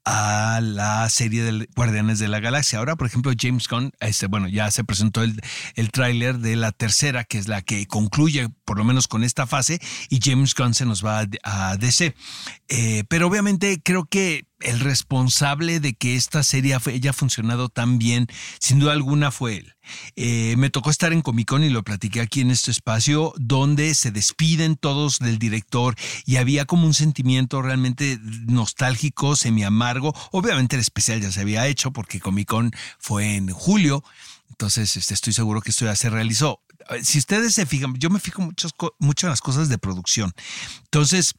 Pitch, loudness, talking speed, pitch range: 125 Hz, -21 LUFS, 185 wpm, 110-145 Hz